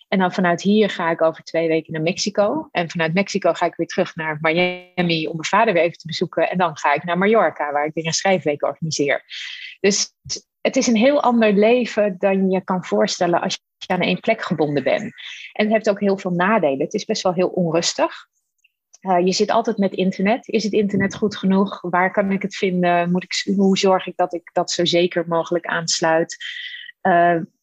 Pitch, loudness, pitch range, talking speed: 185 Hz, -19 LUFS, 170-205 Hz, 215 wpm